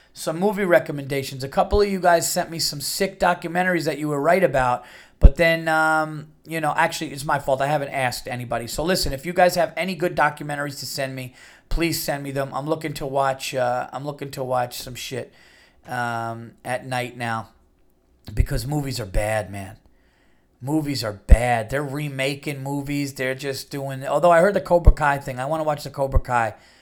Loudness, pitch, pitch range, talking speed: -23 LUFS, 140 Hz, 125-160 Hz, 200 wpm